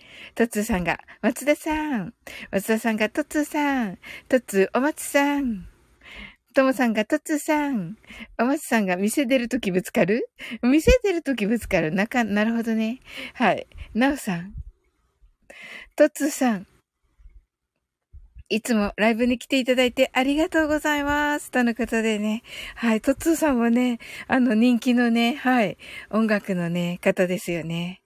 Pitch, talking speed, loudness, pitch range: 235 Hz, 295 characters per minute, -23 LUFS, 210-275 Hz